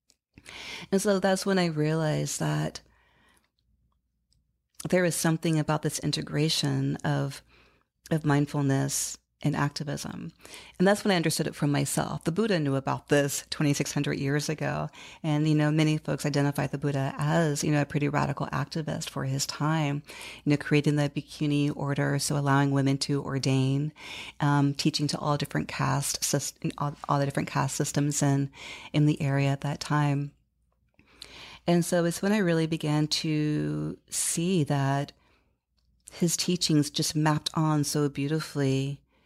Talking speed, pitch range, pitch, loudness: 150 wpm, 140-155 Hz, 145 Hz, -27 LUFS